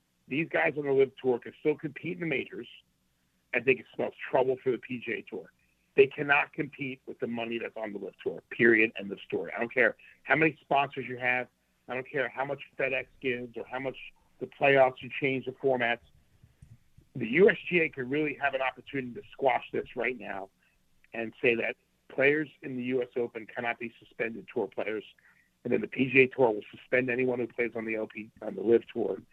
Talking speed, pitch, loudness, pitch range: 210 wpm, 130 Hz, -29 LUFS, 115-140 Hz